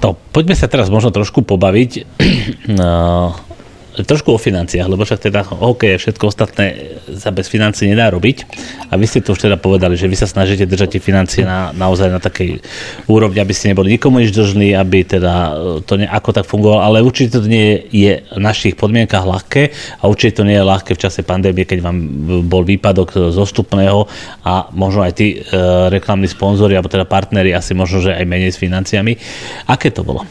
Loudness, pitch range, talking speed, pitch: -13 LUFS, 95-110 Hz, 195 wpm, 100 Hz